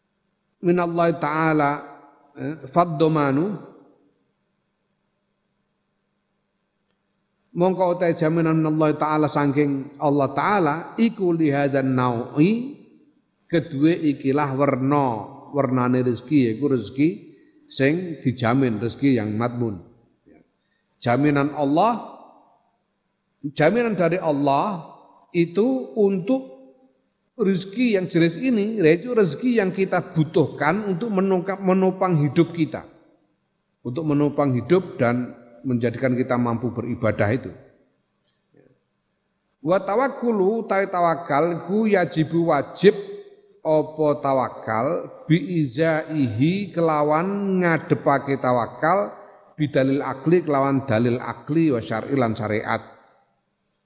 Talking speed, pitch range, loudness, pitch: 85 wpm, 135-185 Hz, -22 LUFS, 155 Hz